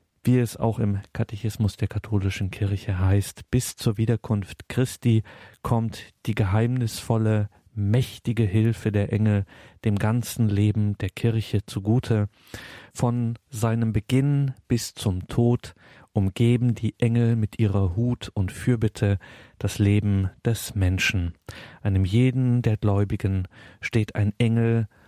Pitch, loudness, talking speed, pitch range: 110 Hz, -24 LUFS, 120 wpm, 100-115 Hz